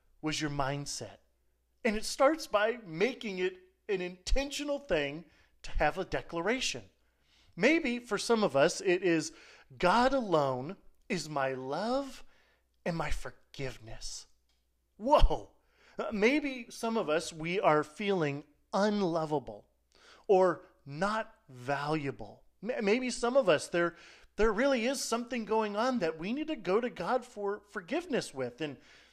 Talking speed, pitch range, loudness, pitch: 135 wpm, 150-230 Hz, -32 LUFS, 190 Hz